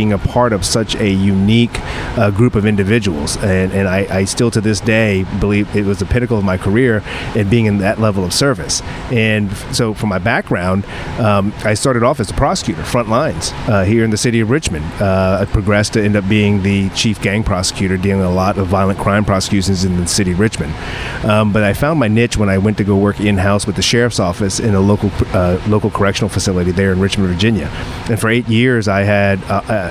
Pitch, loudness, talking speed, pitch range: 105 Hz, -14 LUFS, 230 wpm, 95-110 Hz